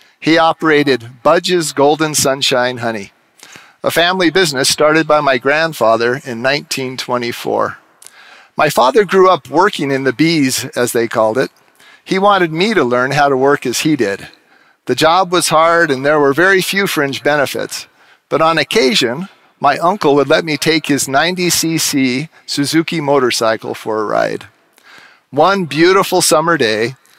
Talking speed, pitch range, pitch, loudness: 150 wpm, 135-165 Hz, 150 Hz, -13 LUFS